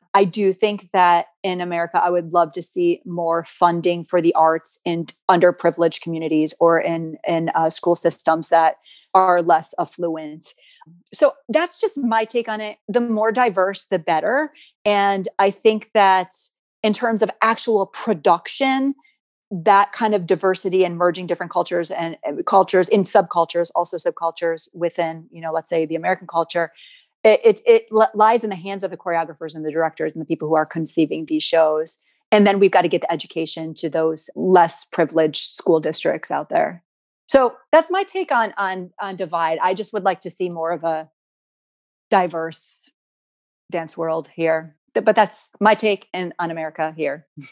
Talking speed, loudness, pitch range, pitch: 175 wpm, -19 LUFS, 165-210 Hz, 175 Hz